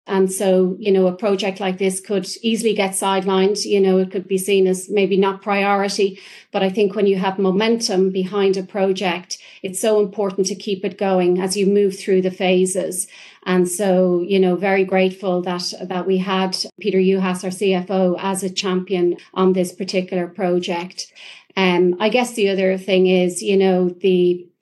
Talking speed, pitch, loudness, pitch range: 190 wpm, 190 Hz, -18 LUFS, 185-200 Hz